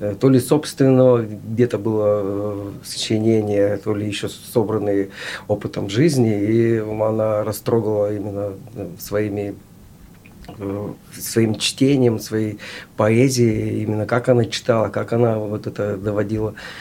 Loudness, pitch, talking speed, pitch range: -20 LUFS, 110 Hz, 105 wpm, 105-115 Hz